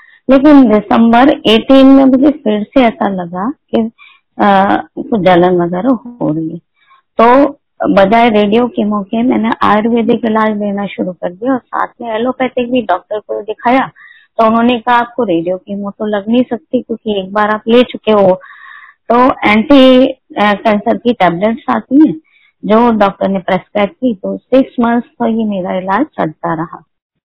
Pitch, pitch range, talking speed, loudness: 230 Hz, 205-260 Hz, 170 wpm, -11 LUFS